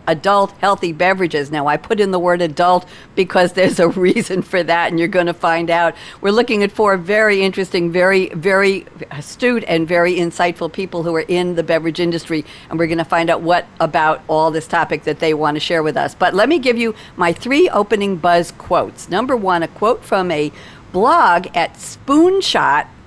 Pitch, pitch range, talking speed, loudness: 175 Hz, 165-195 Hz, 205 wpm, -16 LUFS